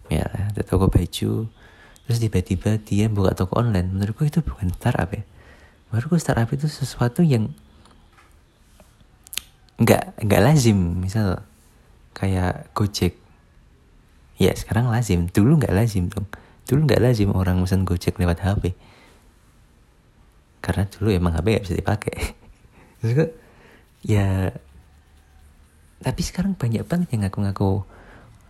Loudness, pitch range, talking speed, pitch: -22 LUFS, 90-115 Hz, 120 wpm, 100 Hz